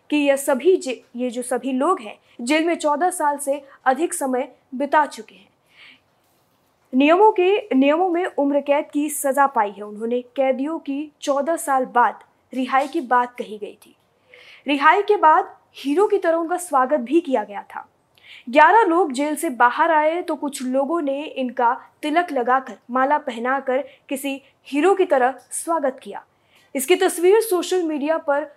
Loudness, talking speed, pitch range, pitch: -20 LUFS, 165 wpm, 260-325 Hz, 285 Hz